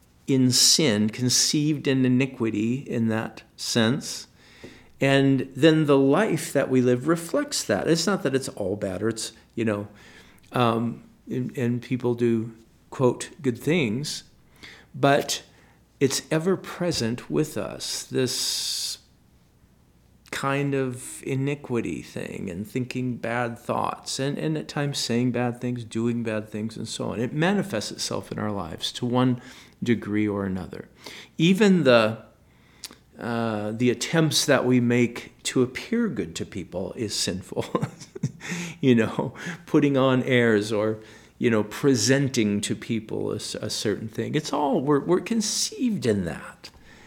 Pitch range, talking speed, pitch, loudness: 115-140 Hz, 140 wpm, 125 Hz, -24 LUFS